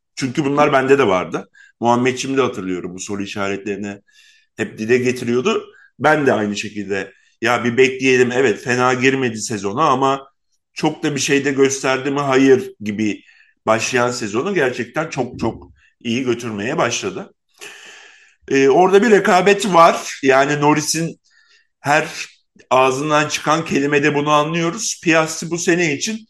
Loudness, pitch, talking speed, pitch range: -17 LUFS, 135 Hz, 135 wpm, 120-170 Hz